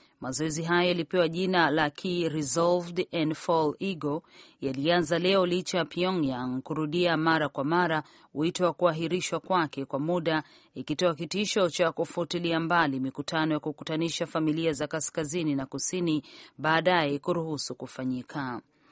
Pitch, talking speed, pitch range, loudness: 165 Hz, 130 wpm, 150-175 Hz, -28 LUFS